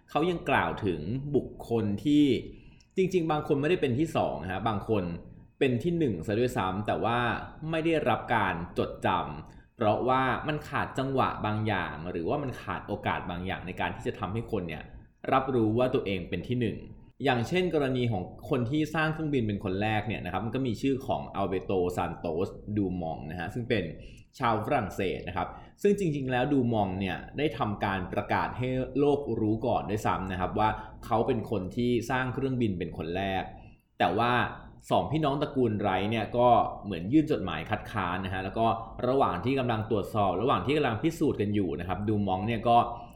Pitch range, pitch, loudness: 95-130 Hz, 115 Hz, -29 LUFS